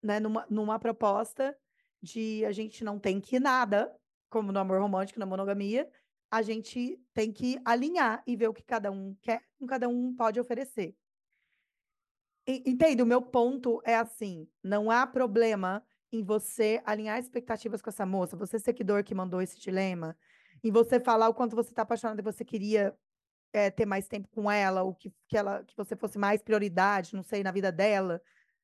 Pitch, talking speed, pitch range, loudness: 220 Hz, 190 wpm, 200-235 Hz, -30 LUFS